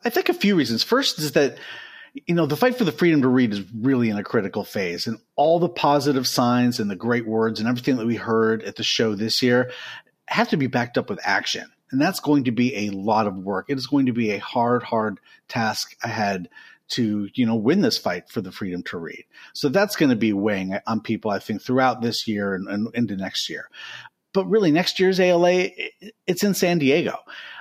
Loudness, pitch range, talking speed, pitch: -22 LUFS, 110-165 Hz, 230 wpm, 125 Hz